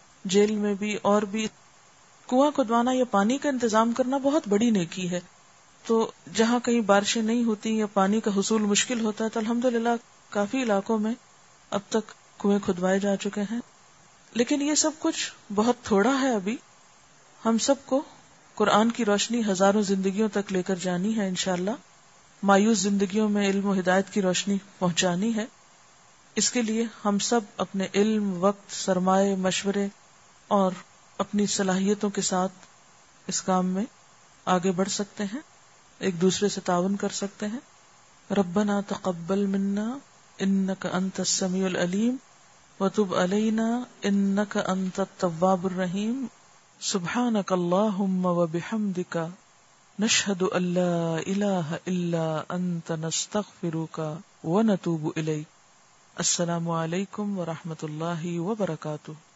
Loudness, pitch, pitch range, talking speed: -26 LUFS, 200 Hz, 185-220 Hz, 135 wpm